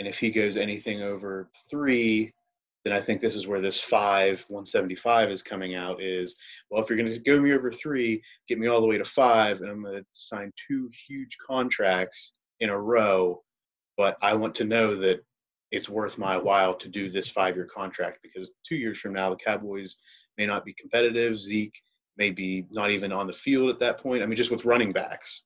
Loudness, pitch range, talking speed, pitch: -26 LUFS, 95-120 Hz, 210 wpm, 105 Hz